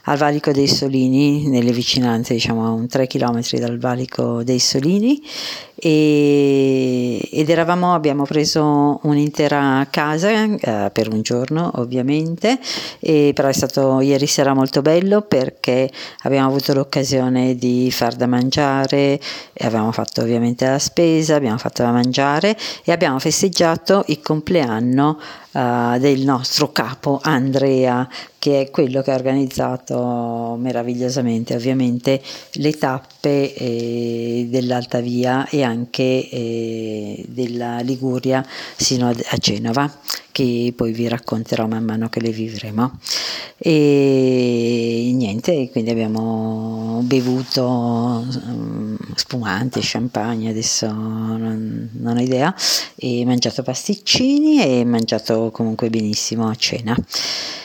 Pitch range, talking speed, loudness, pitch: 120-145 Hz, 120 wpm, -18 LUFS, 130 Hz